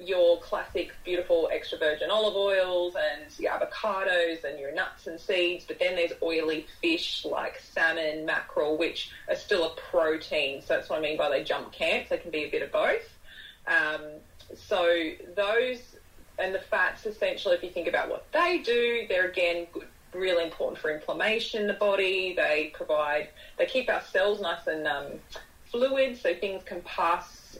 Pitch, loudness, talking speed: 200 Hz, -28 LUFS, 180 wpm